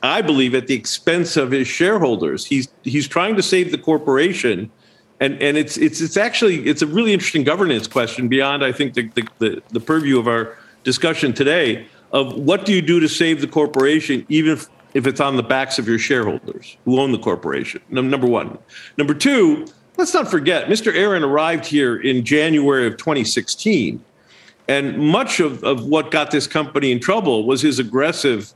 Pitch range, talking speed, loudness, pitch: 130-160 Hz, 185 wpm, -17 LUFS, 145 Hz